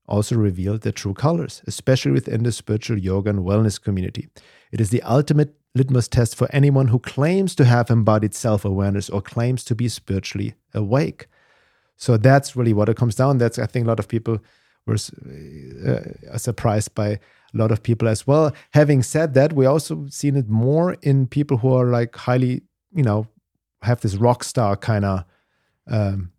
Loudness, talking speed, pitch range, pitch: -20 LUFS, 180 wpm, 105-135 Hz, 120 Hz